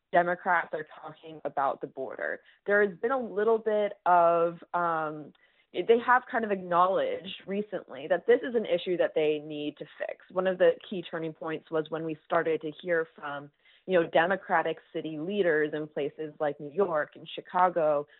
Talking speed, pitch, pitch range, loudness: 180 wpm, 170 Hz, 155-200 Hz, -29 LUFS